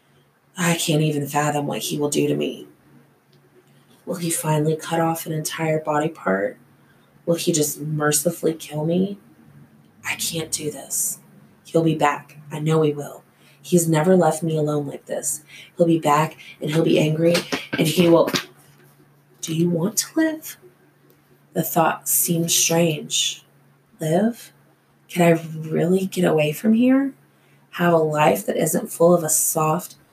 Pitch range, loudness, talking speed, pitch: 150-175 Hz, -21 LUFS, 155 wpm, 160 Hz